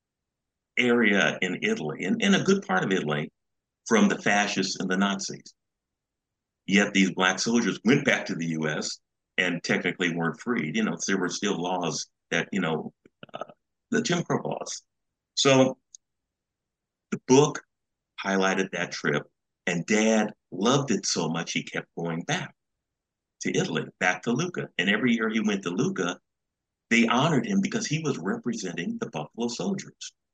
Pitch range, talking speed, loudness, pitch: 90-135 Hz, 160 wpm, -26 LUFS, 105 Hz